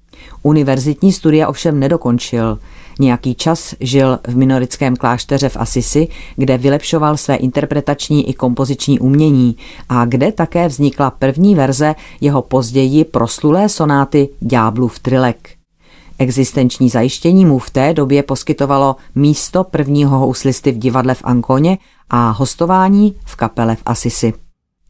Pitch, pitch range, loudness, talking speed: 135 Hz, 125-150 Hz, -13 LUFS, 125 wpm